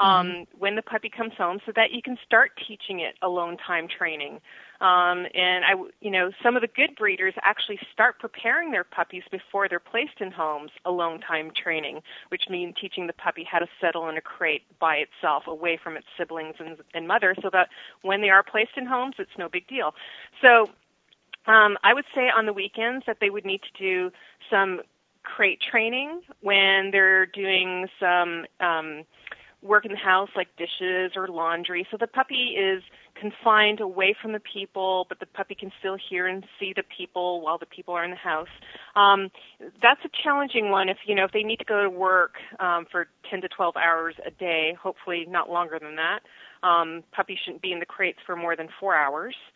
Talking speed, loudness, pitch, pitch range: 205 wpm, -24 LUFS, 190 Hz, 175-215 Hz